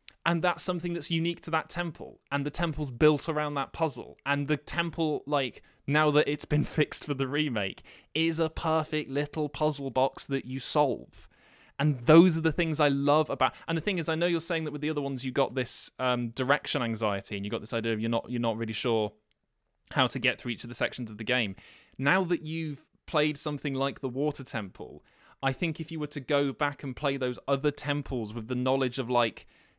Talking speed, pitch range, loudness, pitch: 230 wpm, 125-155 Hz, -29 LUFS, 145 Hz